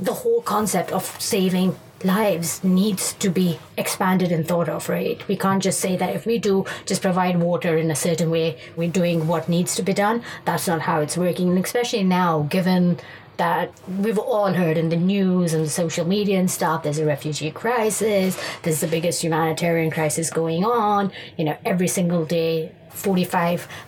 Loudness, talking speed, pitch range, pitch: -21 LUFS, 185 wpm, 165-190 Hz, 175 Hz